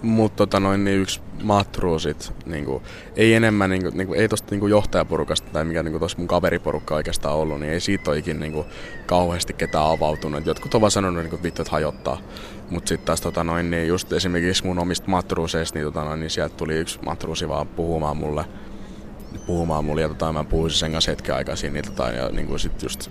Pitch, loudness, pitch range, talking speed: 85 Hz, -23 LUFS, 75-95 Hz, 195 wpm